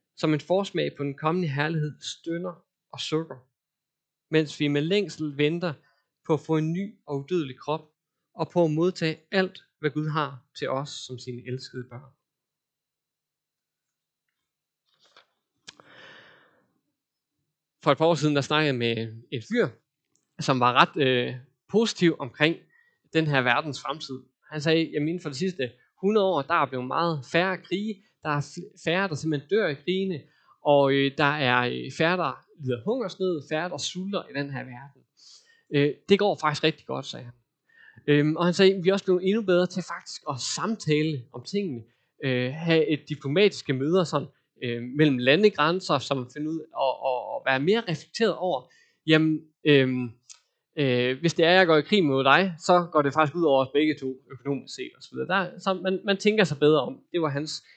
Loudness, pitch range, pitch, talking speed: -25 LUFS, 140-175 Hz, 155 Hz, 185 wpm